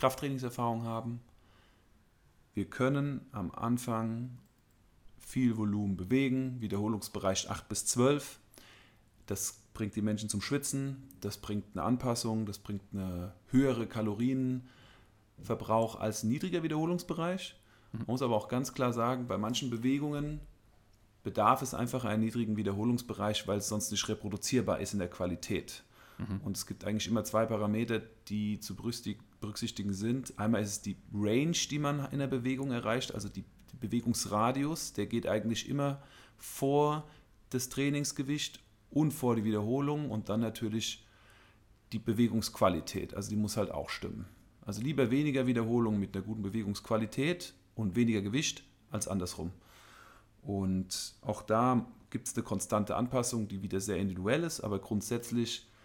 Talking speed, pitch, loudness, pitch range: 140 wpm, 110 Hz, -34 LUFS, 105-125 Hz